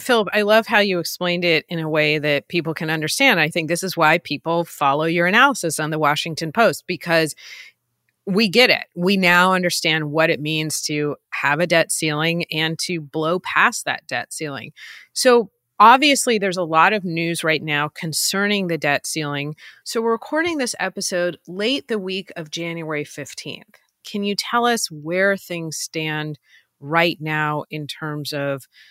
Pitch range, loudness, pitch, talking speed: 155-195 Hz, -19 LUFS, 170 Hz, 175 wpm